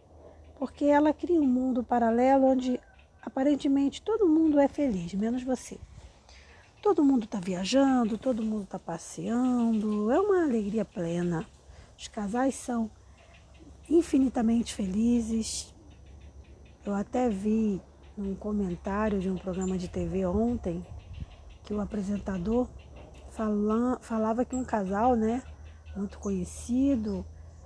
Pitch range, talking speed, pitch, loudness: 190-255 Hz, 115 wpm, 220 Hz, -28 LUFS